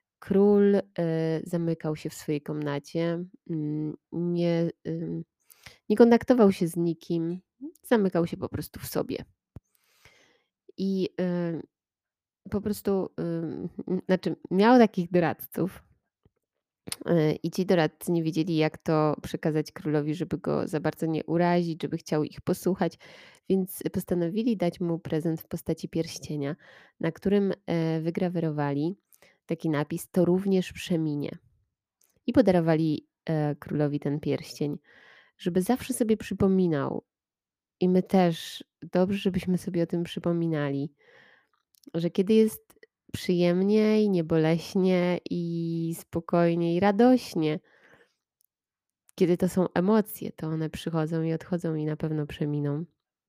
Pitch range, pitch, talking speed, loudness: 155-190 Hz, 170 Hz, 115 wpm, -27 LUFS